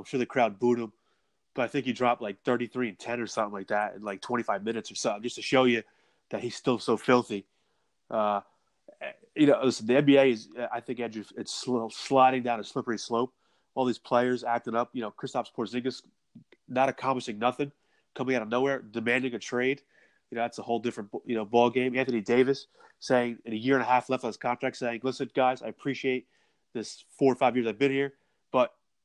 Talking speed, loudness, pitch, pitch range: 215 wpm, -28 LUFS, 125 Hz, 115-130 Hz